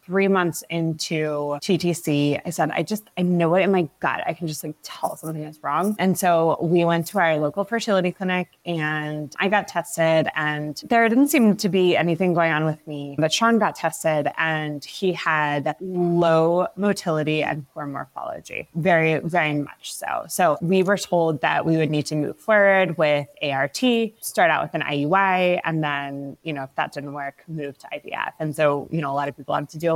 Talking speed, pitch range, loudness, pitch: 205 wpm, 150-185 Hz, -22 LUFS, 165 Hz